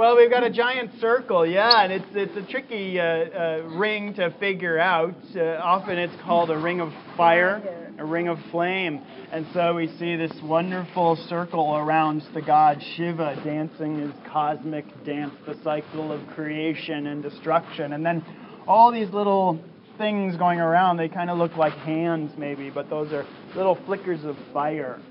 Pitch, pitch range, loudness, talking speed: 170 Hz, 155-190 Hz, -24 LUFS, 175 wpm